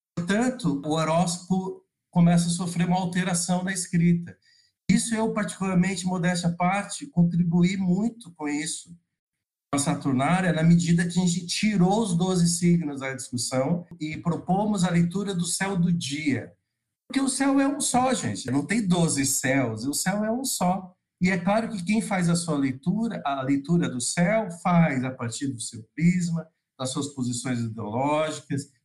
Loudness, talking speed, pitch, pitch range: -25 LUFS, 165 wpm, 175 Hz, 145-190 Hz